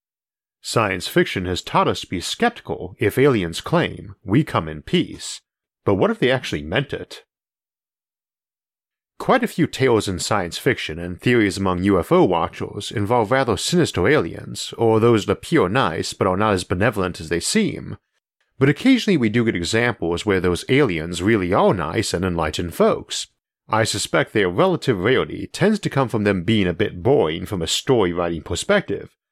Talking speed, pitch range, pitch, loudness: 175 wpm, 90-120 Hz, 100 Hz, -20 LUFS